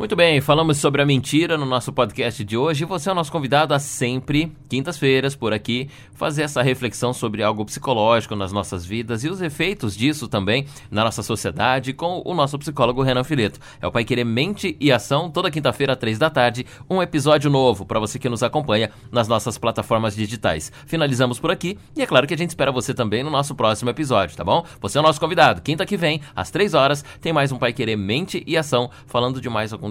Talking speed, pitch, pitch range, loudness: 220 wpm, 130 Hz, 115-155 Hz, -20 LUFS